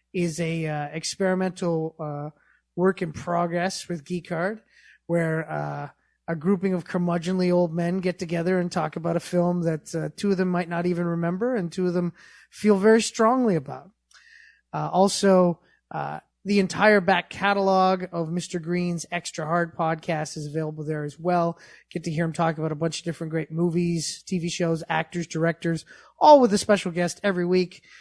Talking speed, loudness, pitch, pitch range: 180 wpm, -24 LUFS, 175 Hz, 165-185 Hz